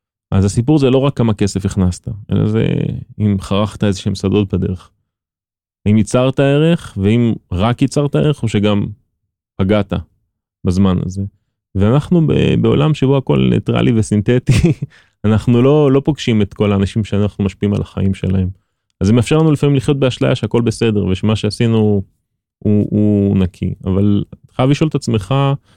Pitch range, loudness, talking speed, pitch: 100-125 Hz, -15 LUFS, 155 wpm, 105 Hz